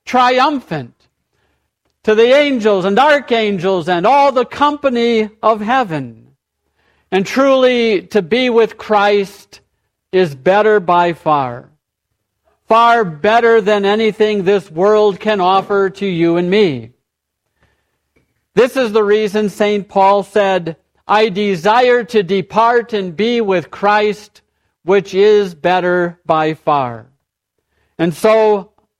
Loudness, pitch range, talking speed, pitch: -13 LUFS, 175-220 Hz, 115 wpm, 205 Hz